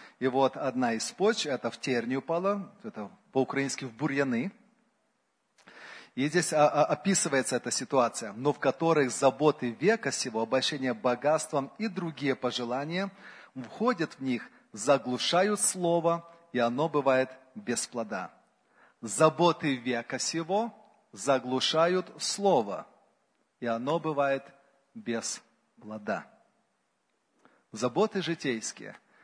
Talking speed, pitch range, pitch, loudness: 105 wpm, 130-180 Hz, 145 Hz, -29 LUFS